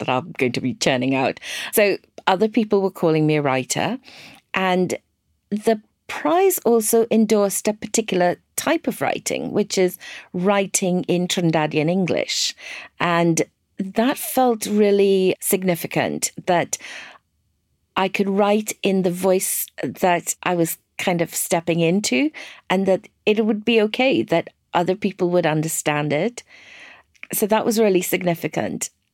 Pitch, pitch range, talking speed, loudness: 185 Hz, 165-215 Hz, 140 wpm, -20 LUFS